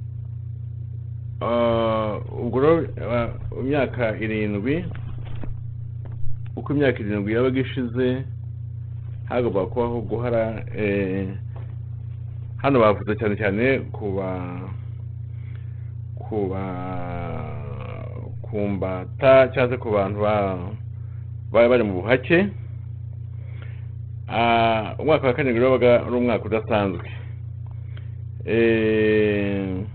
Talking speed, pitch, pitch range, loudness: 80 wpm, 115 Hz, 110-115 Hz, -23 LUFS